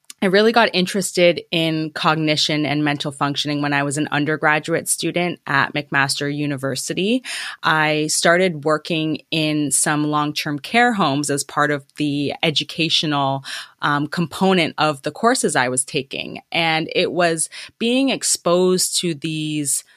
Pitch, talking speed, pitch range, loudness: 155 Hz, 140 wpm, 145-175 Hz, -19 LUFS